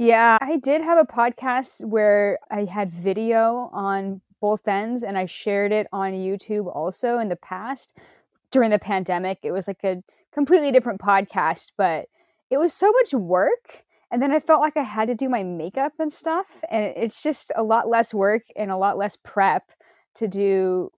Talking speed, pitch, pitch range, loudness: 190 wpm, 220 Hz, 195-265 Hz, -22 LUFS